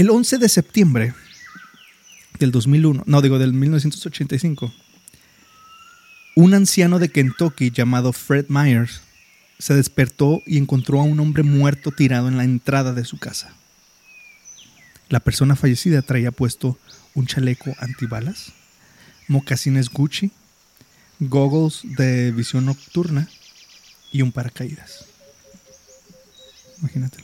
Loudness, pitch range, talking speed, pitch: -18 LUFS, 130-155 Hz, 110 wpm, 140 Hz